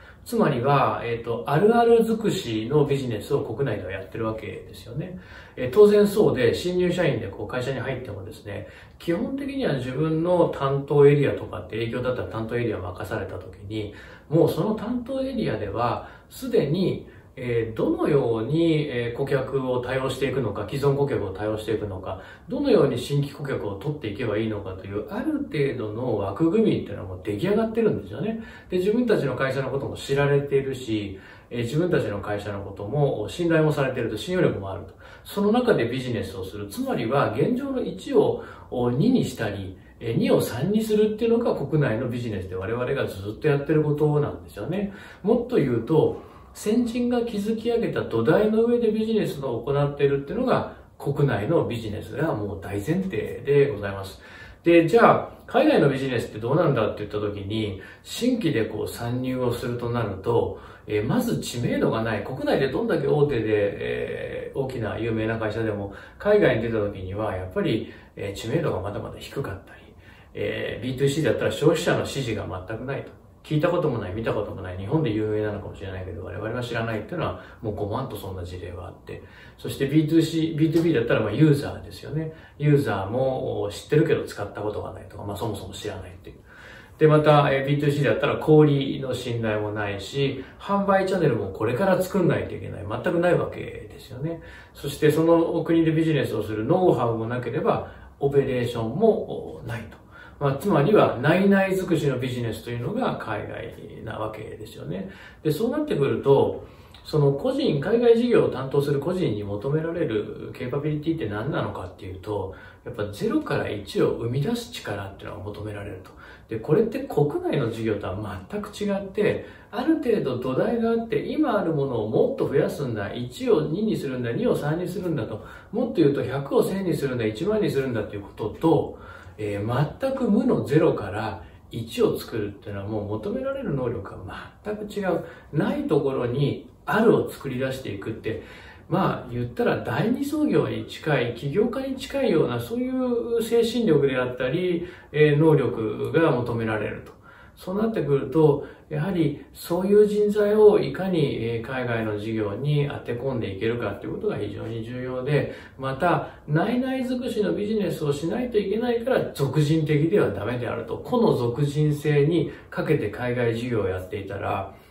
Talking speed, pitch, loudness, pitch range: 375 characters per minute, 135 Hz, -24 LUFS, 110-170 Hz